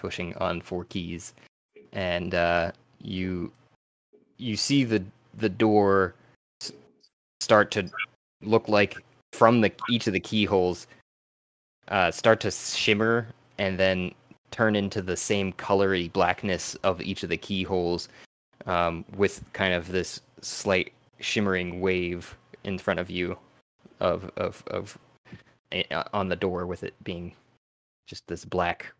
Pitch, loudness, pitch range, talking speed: 95 Hz, -26 LUFS, 90-110 Hz, 130 wpm